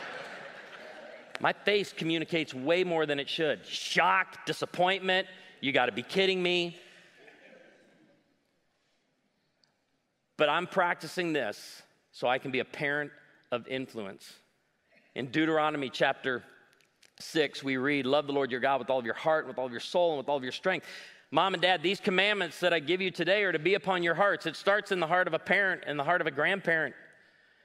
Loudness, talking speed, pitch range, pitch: -29 LUFS, 180 wpm, 140-185 Hz, 165 Hz